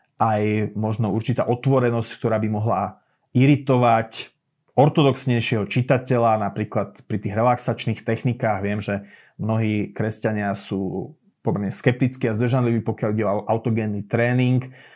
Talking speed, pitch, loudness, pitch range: 115 wpm, 115 Hz, -22 LUFS, 110-125 Hz